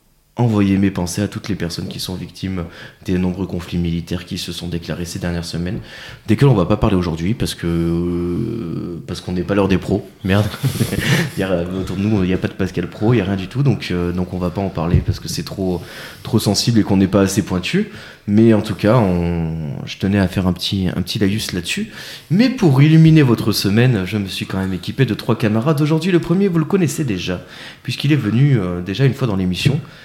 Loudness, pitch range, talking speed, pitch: -18 LUFS, 90-115 Hz, 250 wpm, 100 Hz